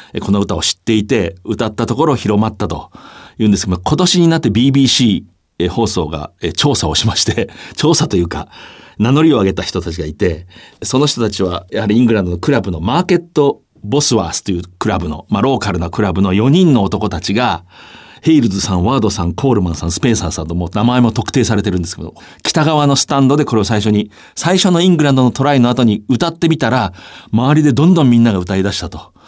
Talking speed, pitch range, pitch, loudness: 440 characters per minute, 90-135 Hz, 110 Hz, -14 LUFS